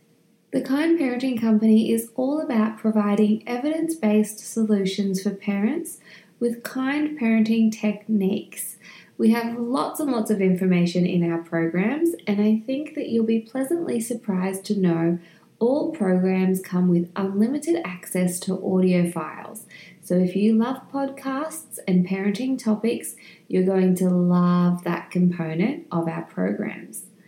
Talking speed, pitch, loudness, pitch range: 140 wpm, 210 Hz, -23 LUFS, 185-240 Hz